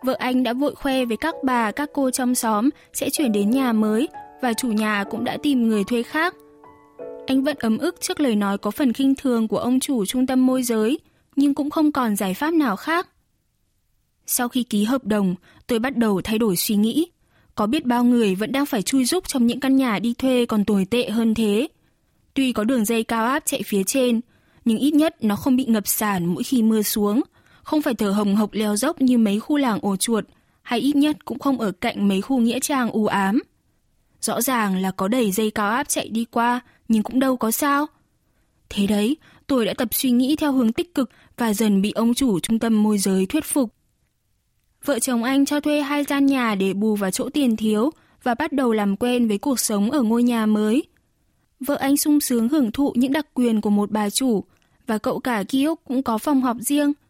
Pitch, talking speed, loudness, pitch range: 245 Hz, 230 wpm, -21 LUFS, 215-275 Hz